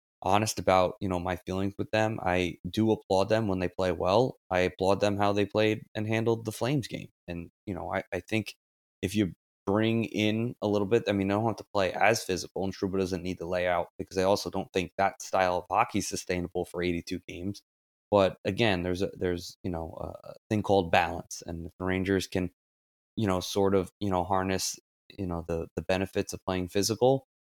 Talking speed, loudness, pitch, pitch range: 220 wpm, -29 LUFS, 95 Hz, 90-105 Hz